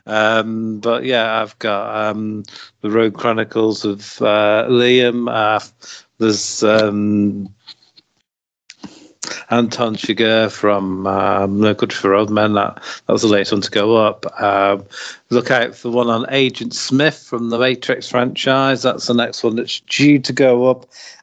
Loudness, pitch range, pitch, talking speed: -16 LUFS, 105-120 Hz, 110 Hz, 155 wpm